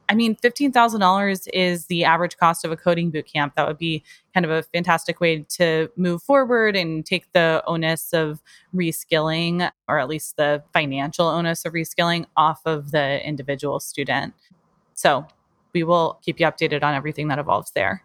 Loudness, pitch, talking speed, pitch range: -21 LUFS, 165 Hz, 175 wpm, 155-175 Hz